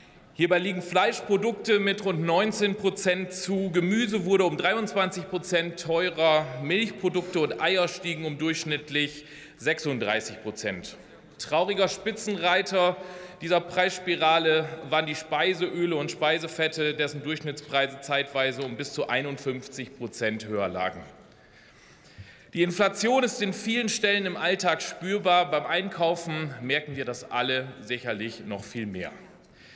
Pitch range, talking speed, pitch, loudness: 145-185 Hz, 120 wpm, 165 Hz, -26 LUFS